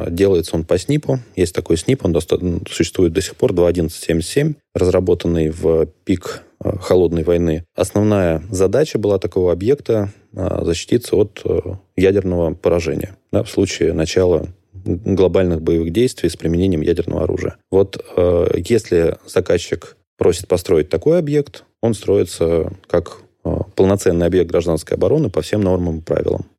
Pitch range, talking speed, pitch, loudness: 85-100 Hz, 140 wpm, 90 Hz, -17 LUFS